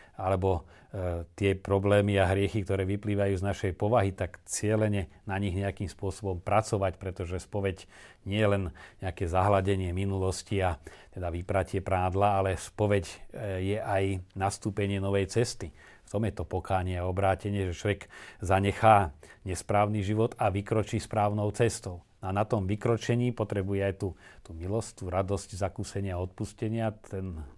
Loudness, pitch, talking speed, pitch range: -30 LUFS, 100 Hz, 150 wpm, 95-105 Hz